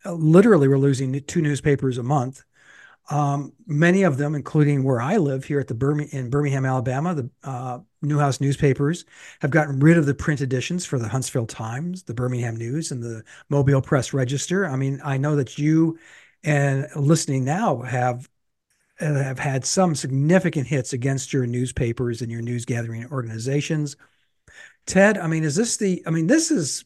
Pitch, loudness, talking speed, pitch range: 140 Hz, -22 LUFS, 175 wpm, 130-155 Hz